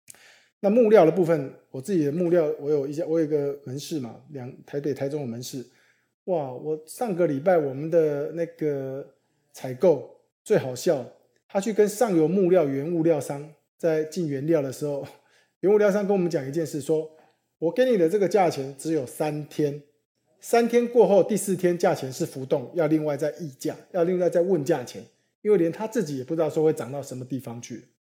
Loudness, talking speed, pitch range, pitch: -24 LUFS, 285 characters per minute, 145-180 Hz, 155 Hz